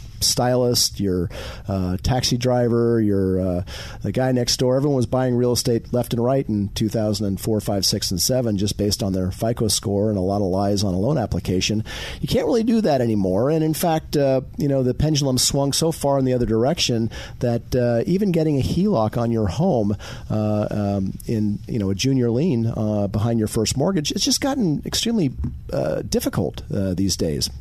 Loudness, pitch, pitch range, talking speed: -21 LUFS, 115 Hz, 100-130 Hz, 200 wpm